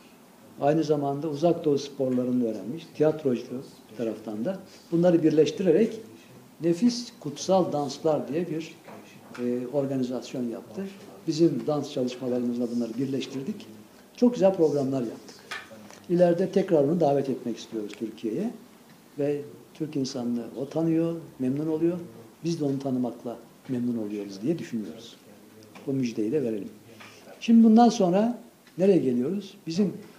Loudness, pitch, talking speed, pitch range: -26 LUFS, 145 Hz, 120 wpm, 125-175 Hz